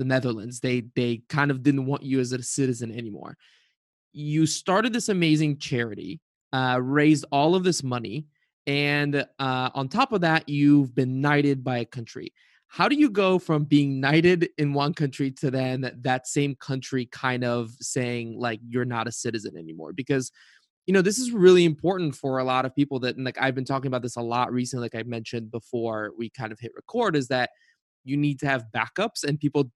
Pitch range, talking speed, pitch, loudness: 125-145 Hz, 205 wpm, 135 Hz, -25 LUFS